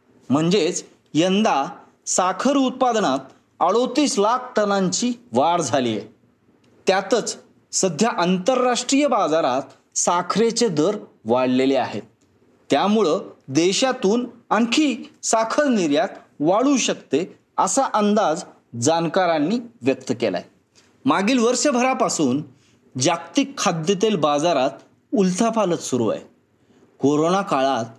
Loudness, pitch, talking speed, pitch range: -20 LUFS, 200 Hz, 90 wpm, 145-245 Hz